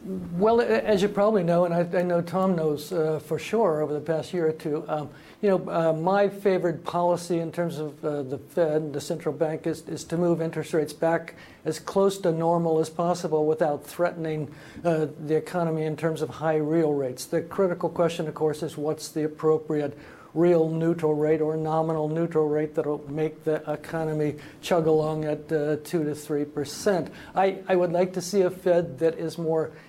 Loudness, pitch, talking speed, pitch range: -26 LUFS, 160 Hz, 200 wpm, 155-175 Hz